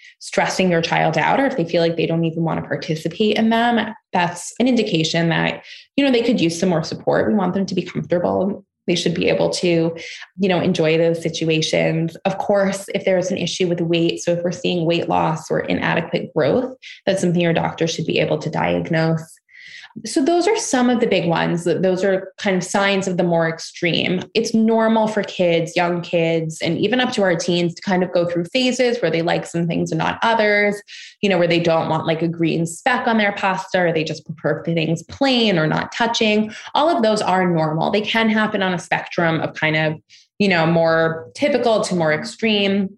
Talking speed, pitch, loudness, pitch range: 220 wpm, 180 Hz, -19 LUFS, 165-215 Hz